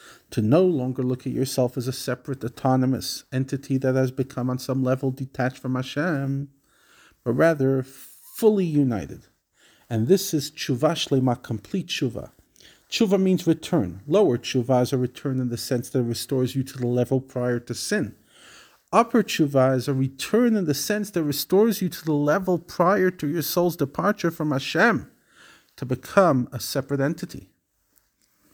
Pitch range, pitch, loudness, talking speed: 130-165 Hz, 135 Hz, -24 LUFS, 165 wpm